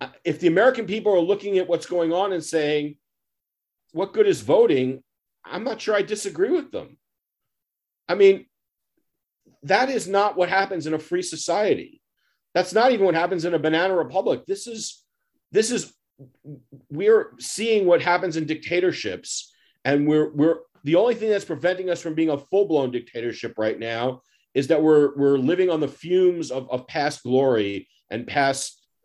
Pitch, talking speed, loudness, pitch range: 170 Hz, 170 wpm, -22 LUFS, 145-200 Hz